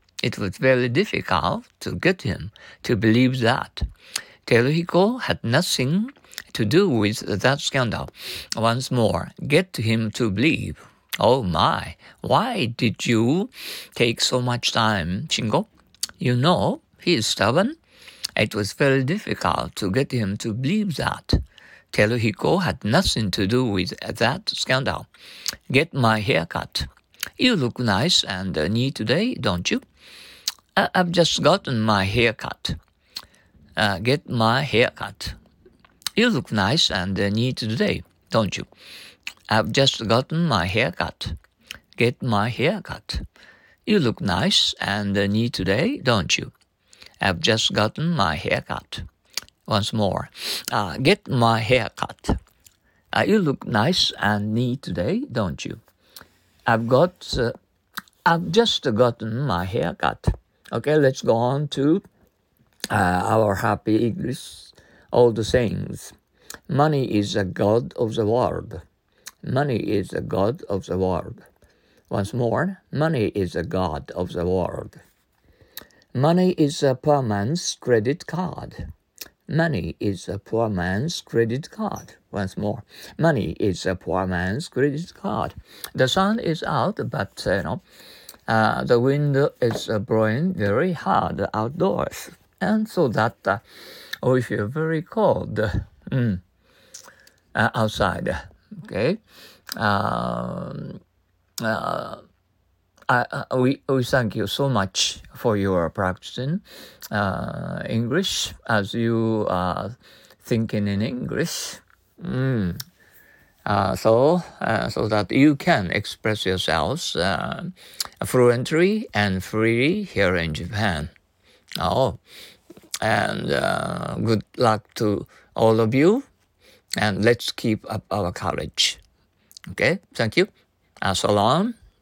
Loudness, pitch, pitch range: -22 LUFS, 115 Hz, 100-135 Hz